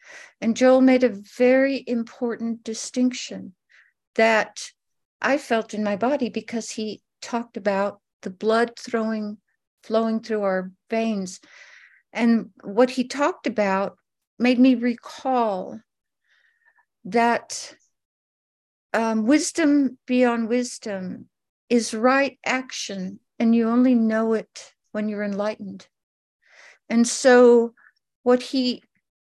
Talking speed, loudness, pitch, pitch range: 105 wpm, -22 LUFS, 235 Hz, 215-255 Hz